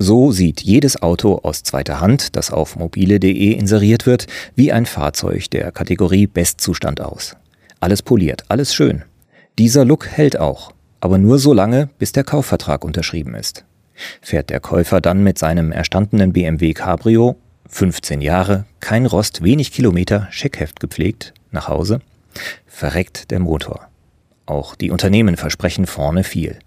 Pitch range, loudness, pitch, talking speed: 85-110 Hz, -16 LUFS, 95 Hz, 145 wpm